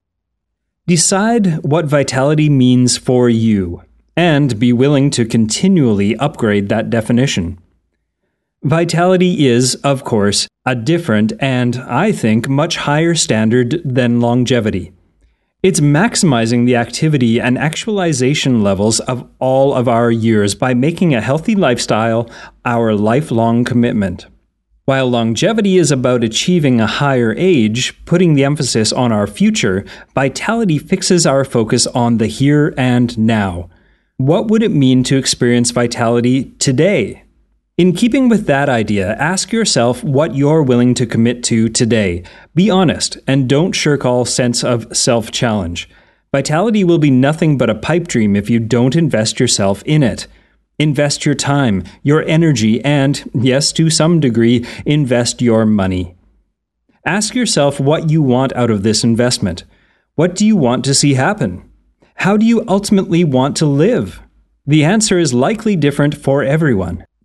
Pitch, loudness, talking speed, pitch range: 130 Hz, -13 LUFS, 145 wpm, 115-155 Hz